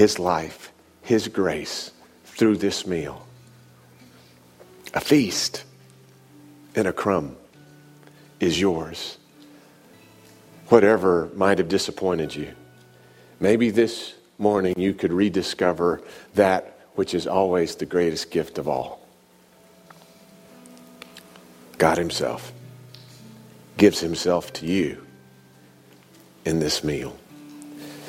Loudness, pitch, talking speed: -23 LUFS, 90 Hz, 90 wpm